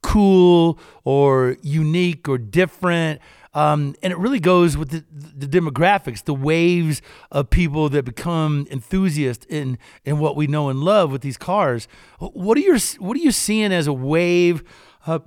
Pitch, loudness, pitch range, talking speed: 160 Hz, -19 LUFS, 145-180 Hz, 170 wpm